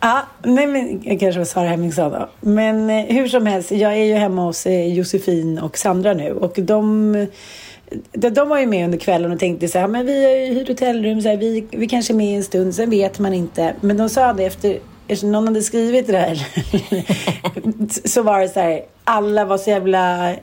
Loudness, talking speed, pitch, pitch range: -18 LUFS, 225 wpm, 205 Hz, 185-220 Hz